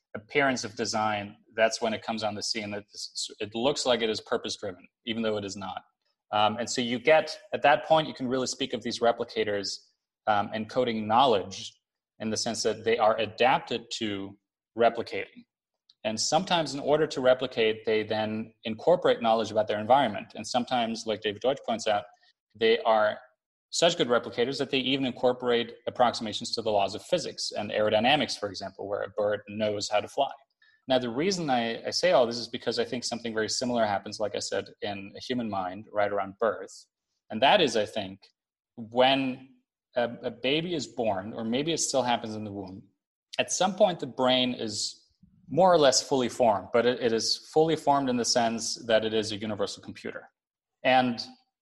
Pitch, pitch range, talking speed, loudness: 115 Hz, 105-130 Hz, 195 wpm, -27 LUFS